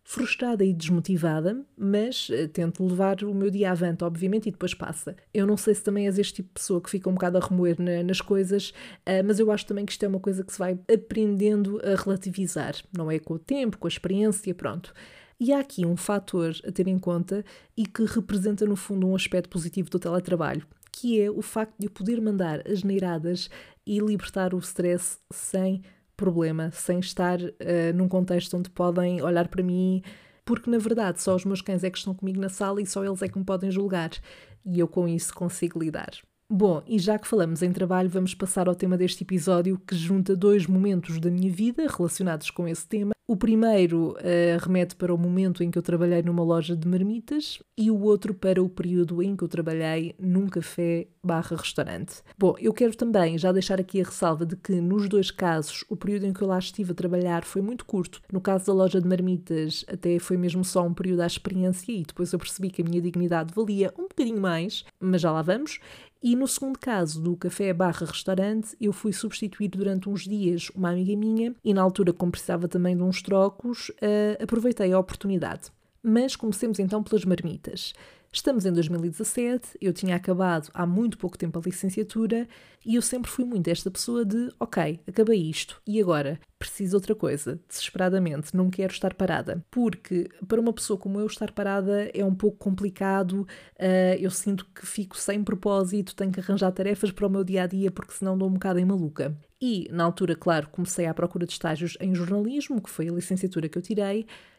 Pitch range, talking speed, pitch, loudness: 175-205 Hz, 205 wpm, 190 Hz, -26 LUFS